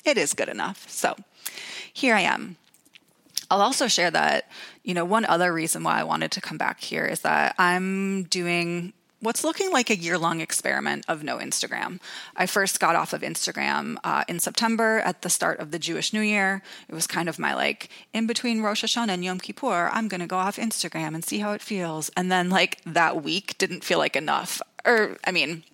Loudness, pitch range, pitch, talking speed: -24 LUFS, 170-220 Hz, 185 Hz, 210 wpm